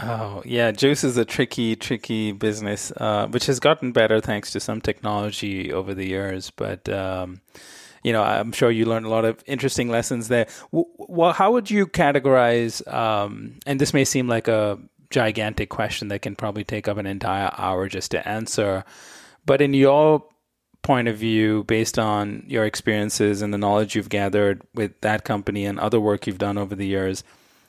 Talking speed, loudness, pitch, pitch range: 185 wpm, -22 LUFS, 110 Hz, 105-125 Hz